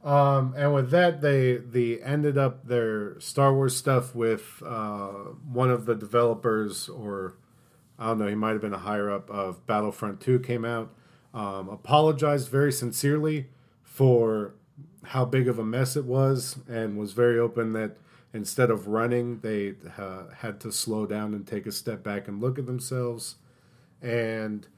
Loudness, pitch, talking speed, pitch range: -27 LUFS, 120 Hz, 170 wpm, 105-135 Hz